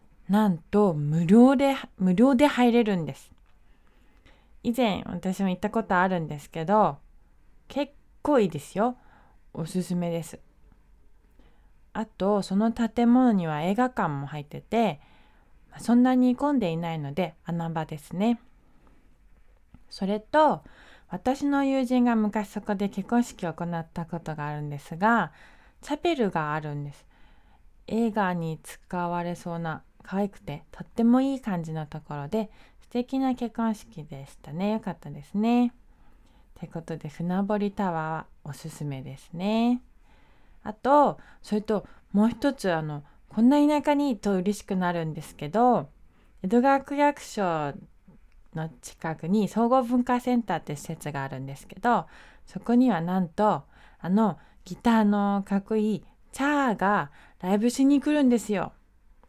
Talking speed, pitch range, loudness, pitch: 270 characters per minute, 165-235 Hz, -26 LUFS, 200 Hz